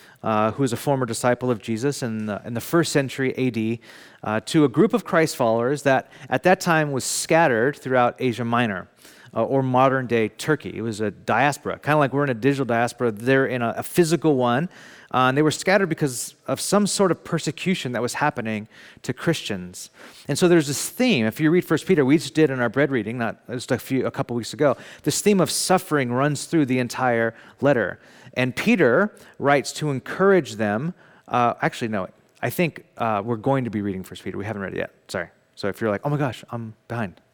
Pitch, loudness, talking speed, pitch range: 130 Hz, -22 LUFS, 220 wpm, 115-155 Hz